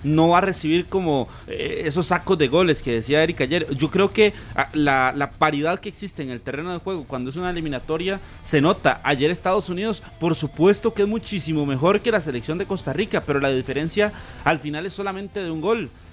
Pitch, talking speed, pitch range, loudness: 165 Hz, 210 wpm, 145-195 Hz, -22 LUFS